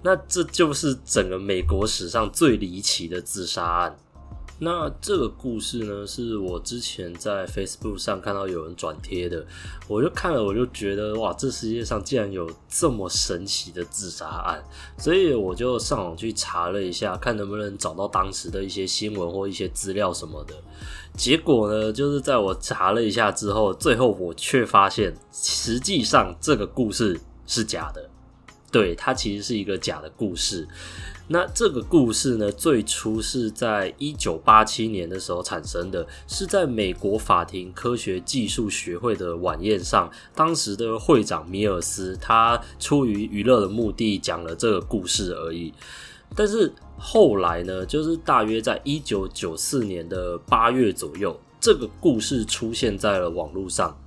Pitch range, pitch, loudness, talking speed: 90-115 Hz, 100 Hz, -23 LUFS, 255 characters per minute